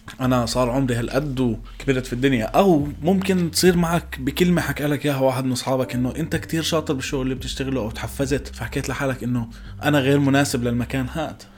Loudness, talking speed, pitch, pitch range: -22 LUFS, 180 wpm, 135 Hz, 125-145 Hz